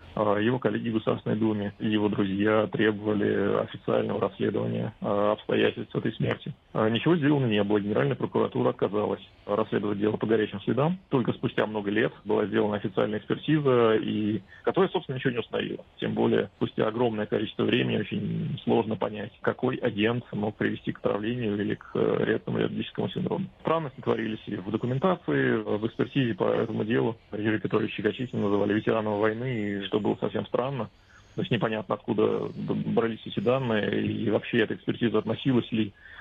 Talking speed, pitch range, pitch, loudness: 155 wpm, 105-125 Hz, 110 Hz, -27 LUFS